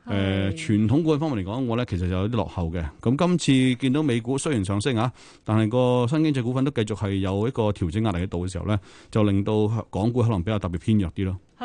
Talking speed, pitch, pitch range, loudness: 370 characters per minute, 110 Hz, 95-125 Hz, -24 LUFS